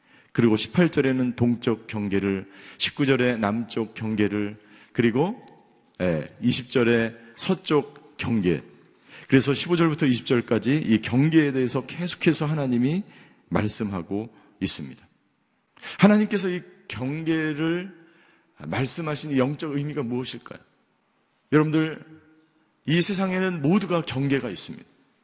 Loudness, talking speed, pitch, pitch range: -24 LUFS, 240 characters per minute, 135 Hz, 115-160 Hz